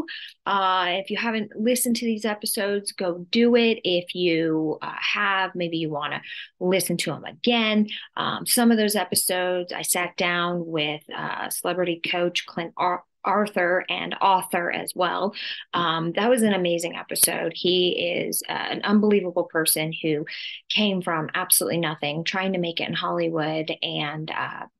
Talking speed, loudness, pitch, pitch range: 160 wpm, -23 LUFS, 180 Hz, 165-205 Hz